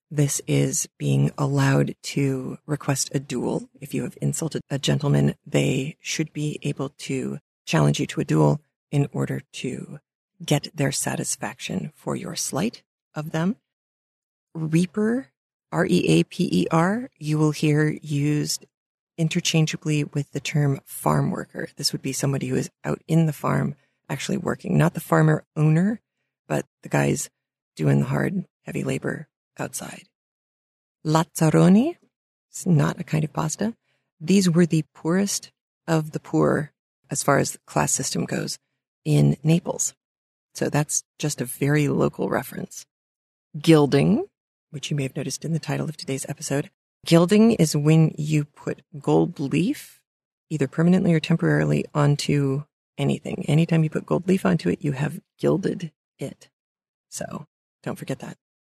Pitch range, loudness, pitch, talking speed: 135-165 Hz, -23 LUFS, 150 Hz, 150 wpm